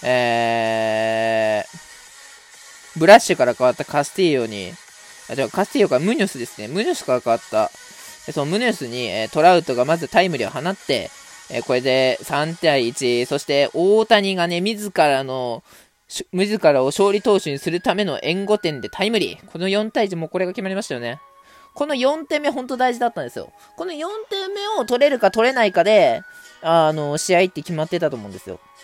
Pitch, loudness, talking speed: 175 Hz, -19 LUFS, 370 characters per minute